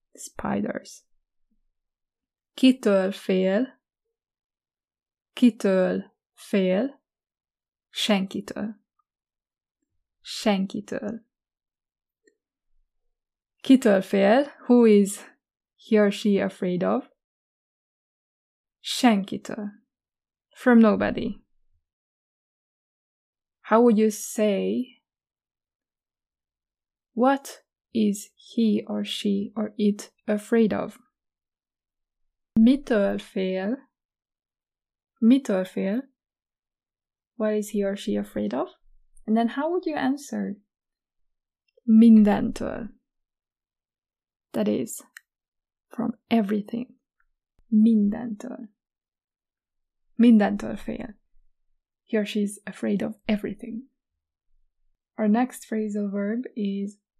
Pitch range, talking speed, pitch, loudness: 205-245 Hz, 70 wpm, 215 Hz, -24 LUFS